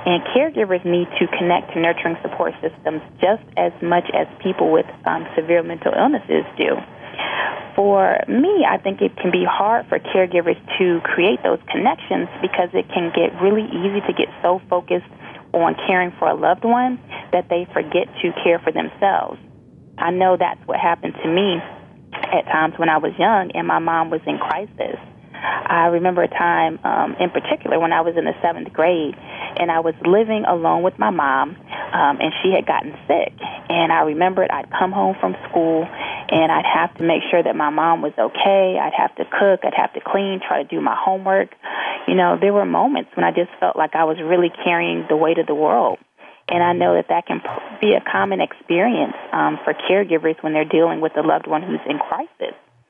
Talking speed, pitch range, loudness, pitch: 200 wpm, 160-190 Hz, -19 LUFS, 175 Hz